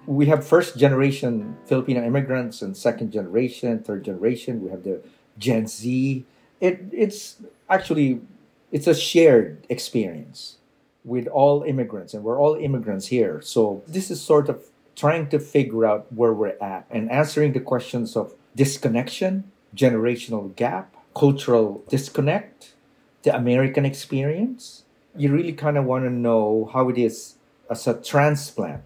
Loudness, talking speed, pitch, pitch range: -22 LUFS, 145 wpm, 135 Hz, 120-150 Hz